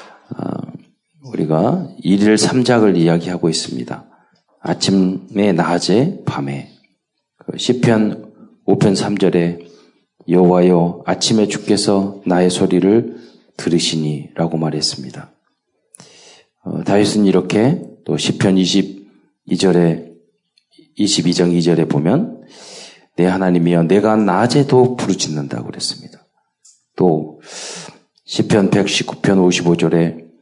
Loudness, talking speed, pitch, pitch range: -15 LUFS, 190 characters per minute, 90 Hz, 85-100 Hz